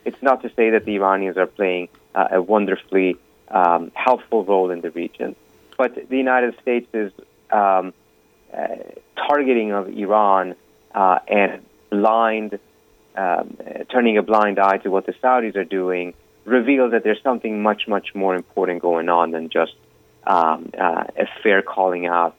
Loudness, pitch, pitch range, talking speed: -19 LUFS, 95 Hz, 90-110 Hz, 160 wpm